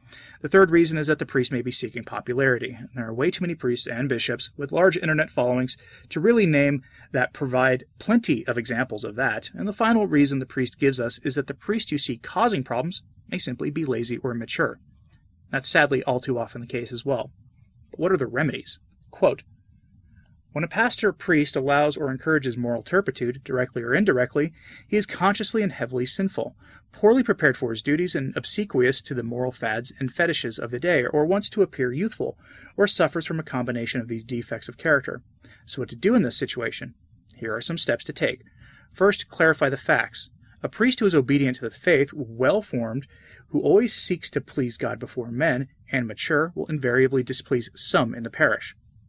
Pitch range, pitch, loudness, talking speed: 125-170 Hz, 135 Hz, -24 LUFS, 200 wpm